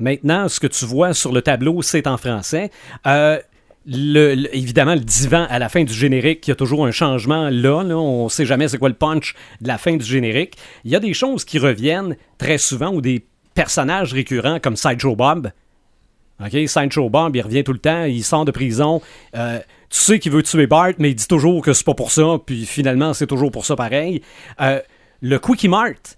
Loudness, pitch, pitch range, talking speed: -17 LUFS, 145 Hz, 130-160 Hz, 225 wpm